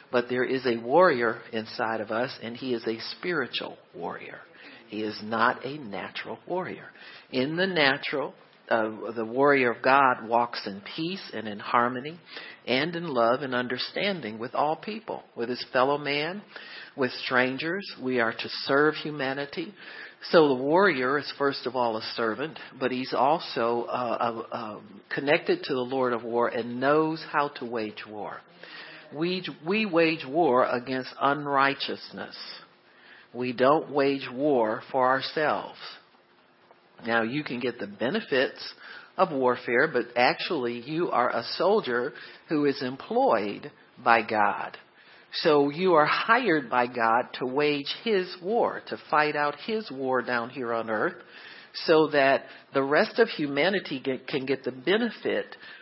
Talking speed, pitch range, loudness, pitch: 150 wpm, 120-150 Hz, -26 LUFS, 130 Hz